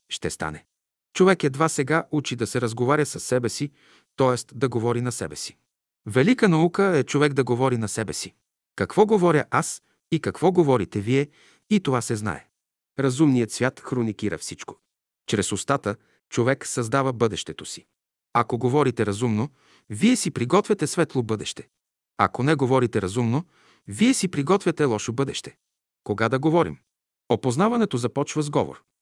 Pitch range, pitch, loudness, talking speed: 120-155 Hz, 135 Hz, -23 LUFS, 150 wpm